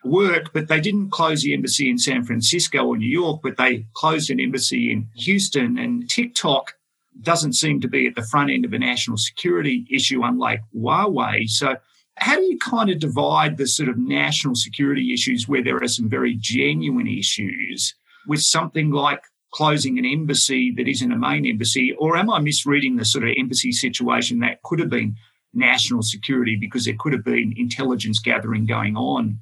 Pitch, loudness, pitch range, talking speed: 135 Hz, -20 LUFS, 120-165 Hz, 190 wpm